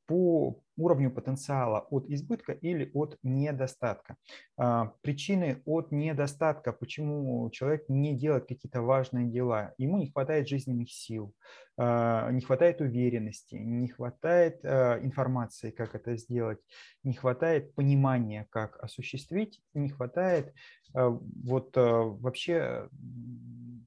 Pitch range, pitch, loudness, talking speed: 120-145 Hz, 130 Hz, -31 LUFS, 105 wpm